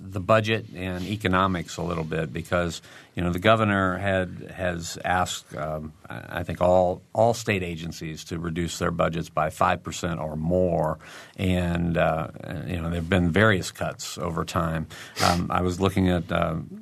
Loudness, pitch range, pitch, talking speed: -25 LUFS, 85-95 Hz, 90 Hz, 170 wpm